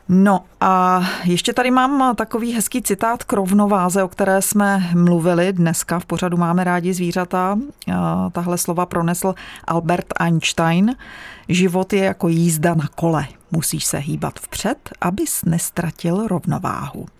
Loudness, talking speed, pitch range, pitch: -18 LUFS, 135 wpm, 170-200 Hz, 185 Hz